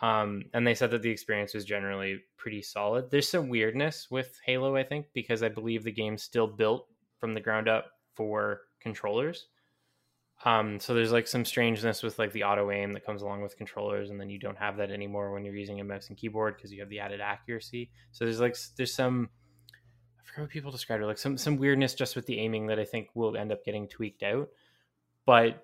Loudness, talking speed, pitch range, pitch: -31 LUFS, 225 wpm, 100-120 Hz, 110 Hz